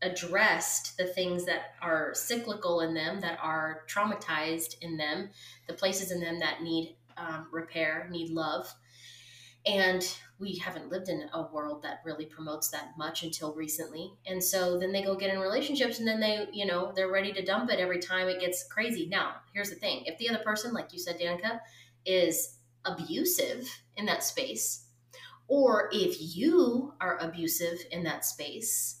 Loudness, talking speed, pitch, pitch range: -31 LUFS, 175 wpm, 175 Hz, 160-195 Hz